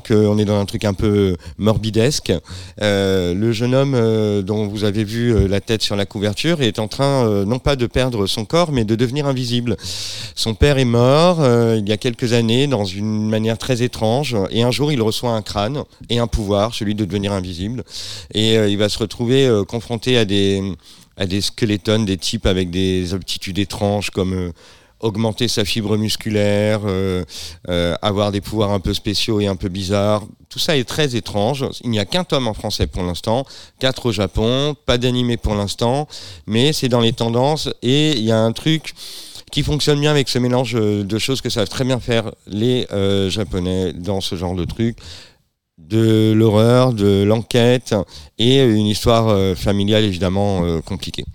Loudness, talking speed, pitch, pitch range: -18 LUFS, 195 wpm, 110 Hz, 100-120 Hz